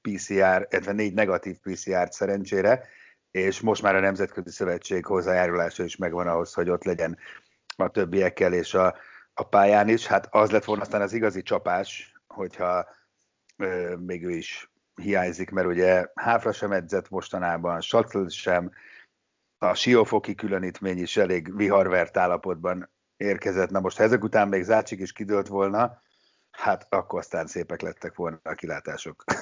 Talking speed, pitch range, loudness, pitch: 150 wpm, 90-100 Hz, -25 LUFS, 95 Hz